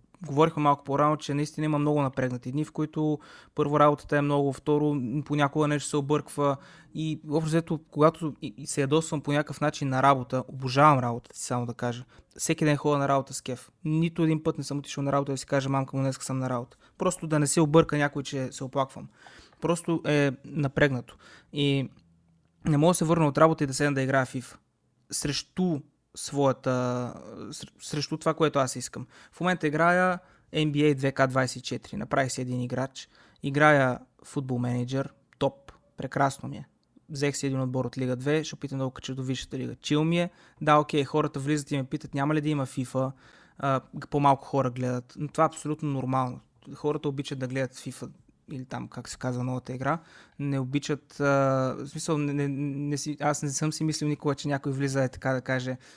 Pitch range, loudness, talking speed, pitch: 130-150 Hz, -27 LUFS, 195 wpm, 145 Hz